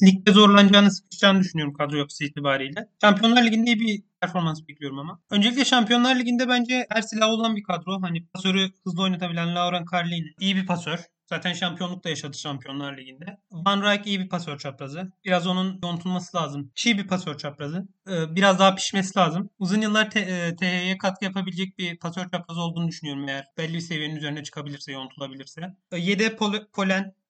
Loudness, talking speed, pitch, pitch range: -23 LUFS, 170 wpm, 185 Hz, 165-200 Hz